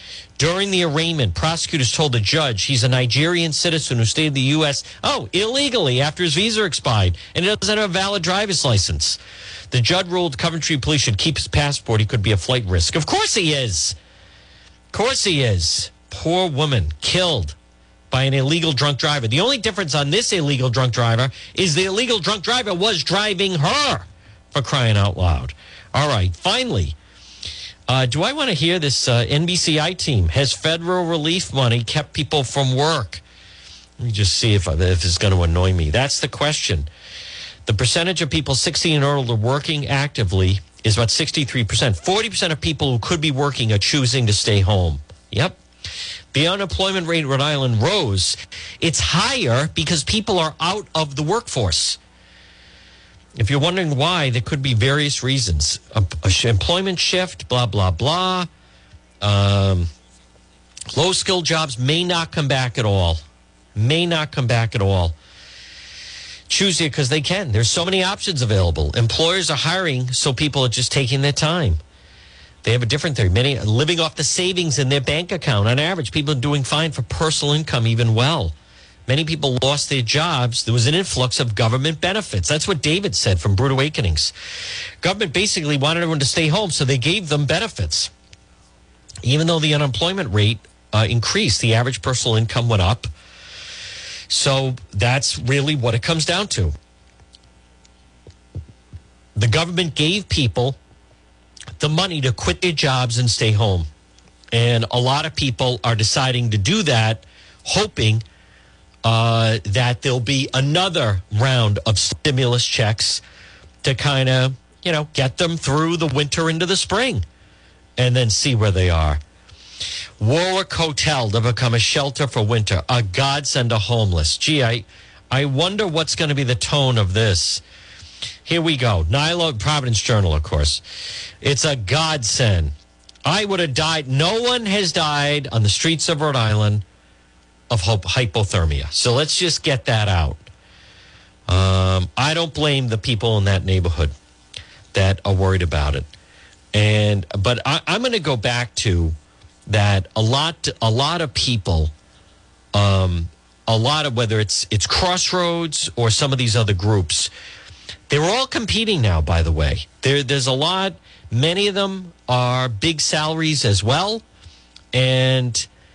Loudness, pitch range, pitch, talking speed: -18 LUFS, 100-155 Hz, 125 Hz, 165 wpm